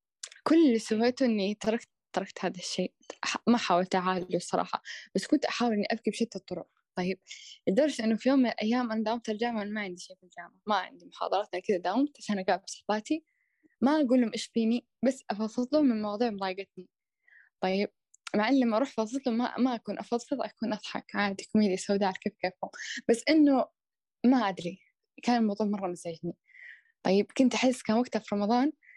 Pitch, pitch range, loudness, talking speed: 220 Hz, 195-255 Hz, -29 LUFS, 180 wpm